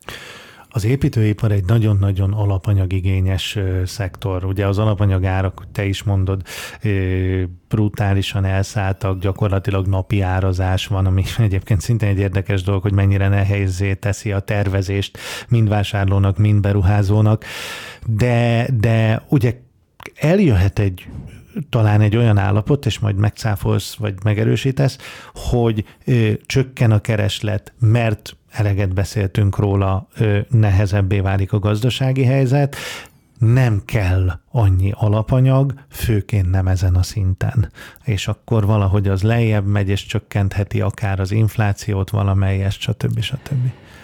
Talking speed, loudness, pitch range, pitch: 115 wpm, -18 LUFS, 95-110 Hz, 105 Hz